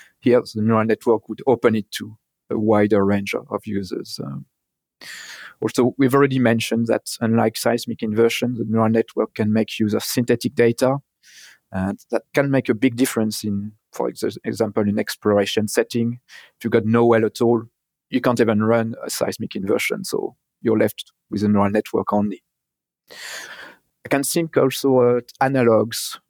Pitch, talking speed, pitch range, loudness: 115 Hz, 170 wpm, 110-125 Hz, -20 LUFS